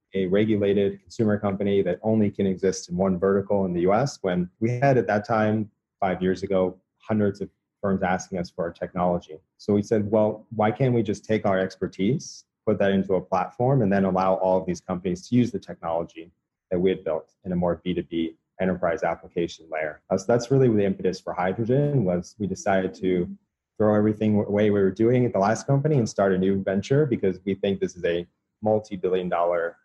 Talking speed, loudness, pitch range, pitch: 215 wpm, -24 LUFS, 95-110 Hz, 100 Hz